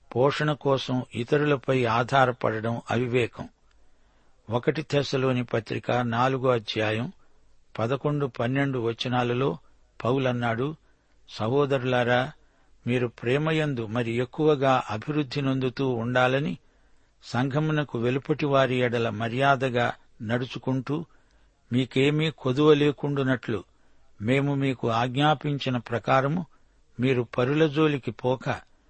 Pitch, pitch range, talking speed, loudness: 130 Hz, 120-140 Hz, 80 wpm, -26 LUFS